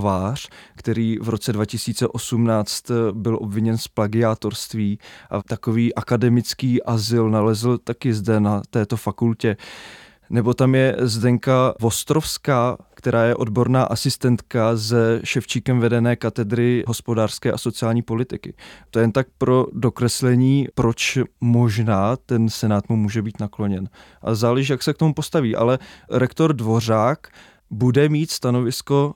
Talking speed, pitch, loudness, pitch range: 130 wpm, 115 Hz, -20 LUFS, 110-125 Hz